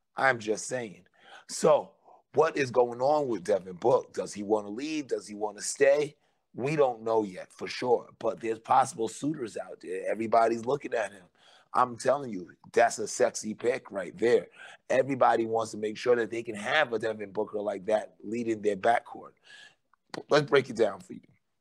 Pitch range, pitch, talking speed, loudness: 110-150 Hz, 115 Hz, 190 wpm, -29 LUFS